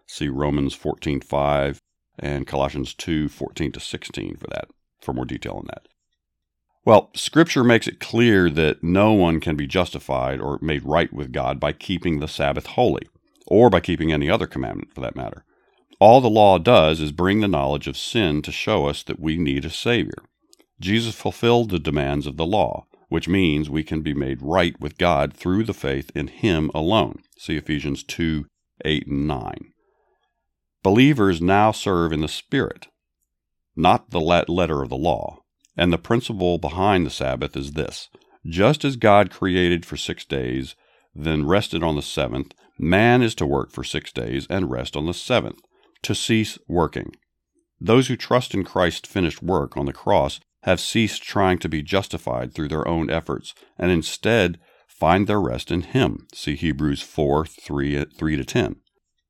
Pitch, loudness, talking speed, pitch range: 80 Hz, -21 LUFS, 170 wpm, 70-95 Hz